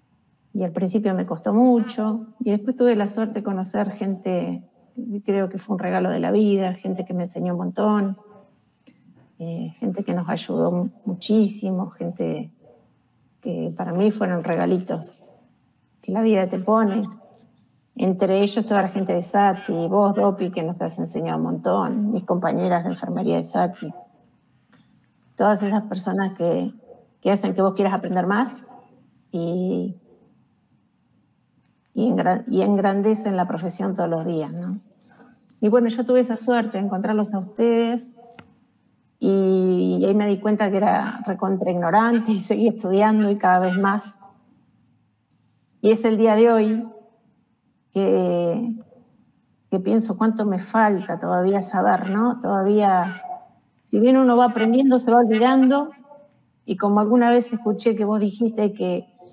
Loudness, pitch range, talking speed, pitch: -21 LUFS, 185-225 Hz, 150 wpm, 205 Hz